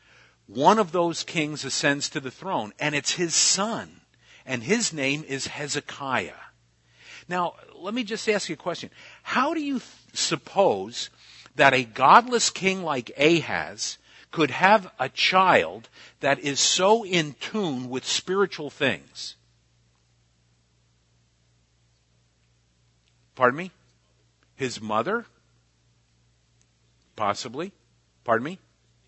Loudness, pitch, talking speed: -24 LUFS, 130 Hz, 115 wpm